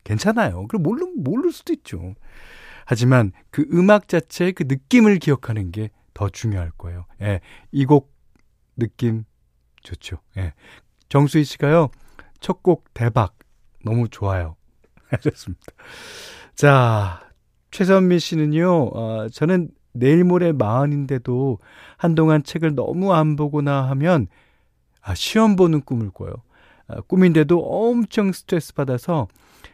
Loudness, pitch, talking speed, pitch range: -19 LUFS, 140 Hz, 240 characters per minute, 110-175 Hz